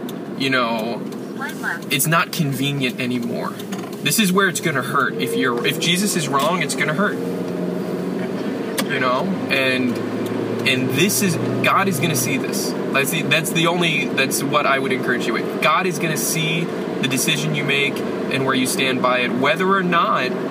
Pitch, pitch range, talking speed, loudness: 165 Hz, 125-190 Hz, 175 wpm, -19 LUFS